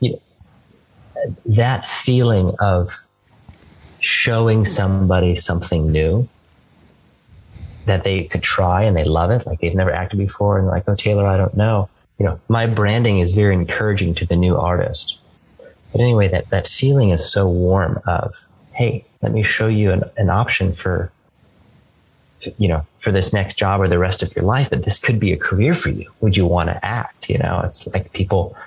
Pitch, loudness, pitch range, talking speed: 95 Hz, -17 LUFS, 90-110 Hz, 185 wpm